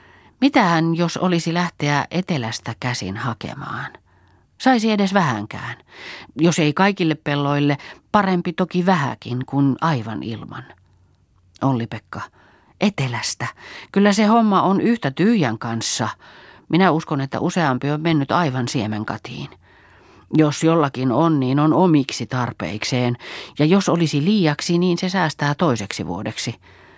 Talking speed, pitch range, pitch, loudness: 120 wpm, 115-175 Hz, 145 Hz, -20 LUFS